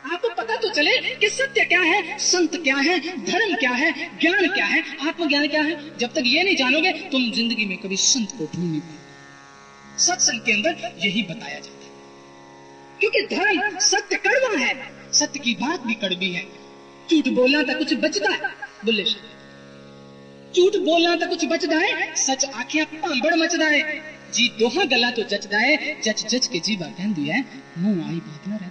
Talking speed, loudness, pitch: 180 wpm, -20 LUFS, 275 Hz